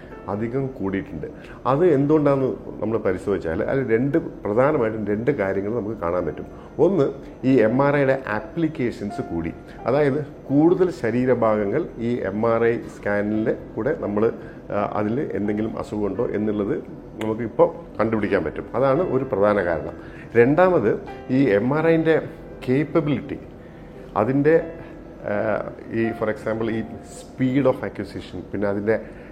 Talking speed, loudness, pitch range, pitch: 120 wpm, -22 LUFS, 105-140 Hz, 115 Hz